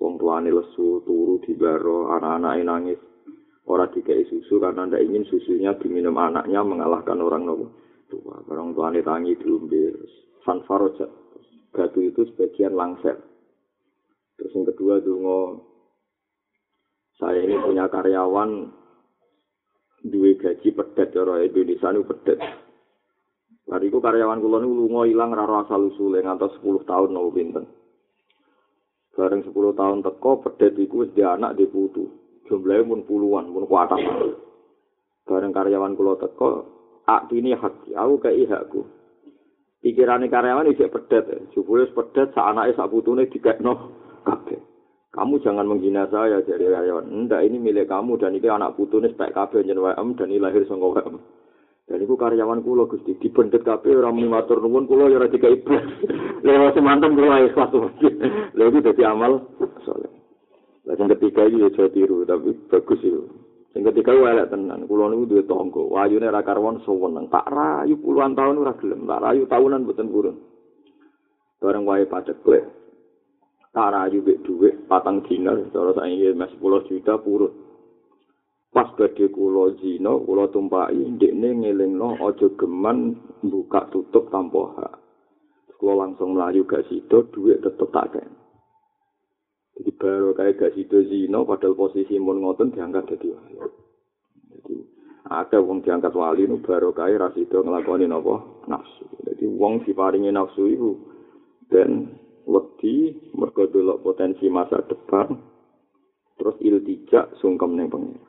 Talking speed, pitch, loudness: 145 wpm, 305 Hz, -20 LUFS